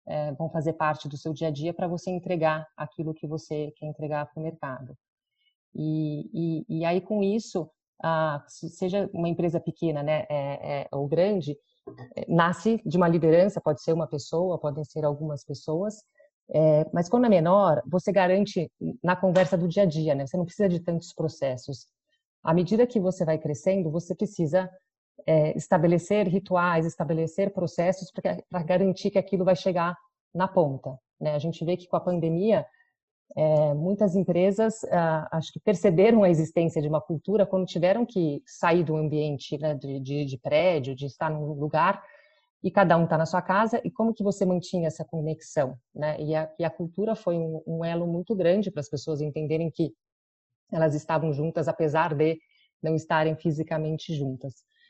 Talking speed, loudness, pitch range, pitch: 180 wpm, -26 LUFS, 155-185 Hz, 165 Hz